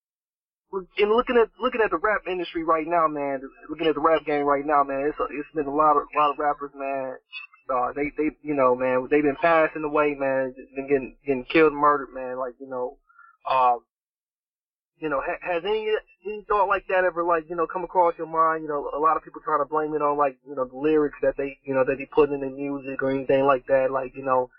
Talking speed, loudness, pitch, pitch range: 250 wpm, -24 LUFS, 145 Hz, 135-165 Hz